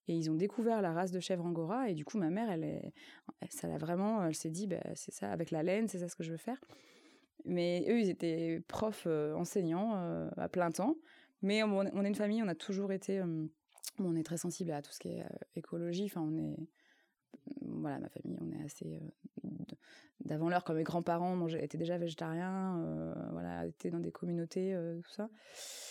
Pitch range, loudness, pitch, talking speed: 160-200 Hz, -38 LUFS, 175 Hz, 225 wpm